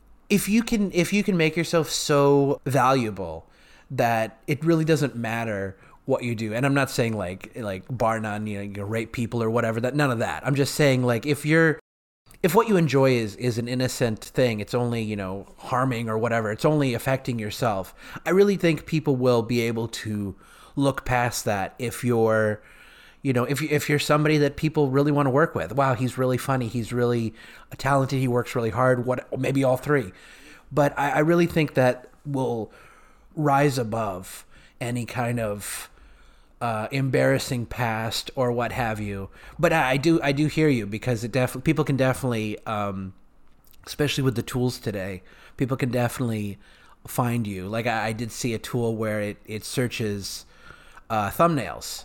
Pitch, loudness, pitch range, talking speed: 125 Hz, -24 LUFS, 110-140 Hz, 185 wpm